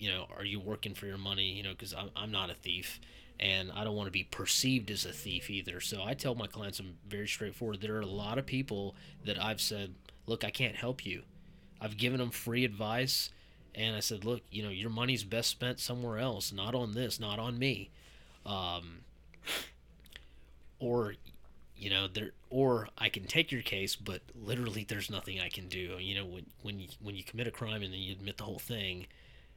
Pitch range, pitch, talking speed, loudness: 95-115 Hz, 105 Hz, 215 wpm, -36 LUFS